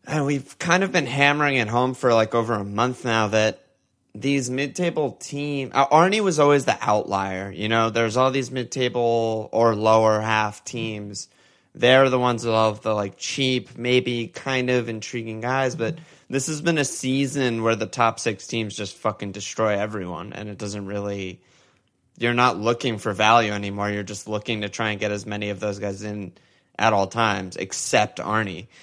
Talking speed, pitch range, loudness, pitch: 190 wpm, 105-130 Hz, -22 LUFS, 115 Hz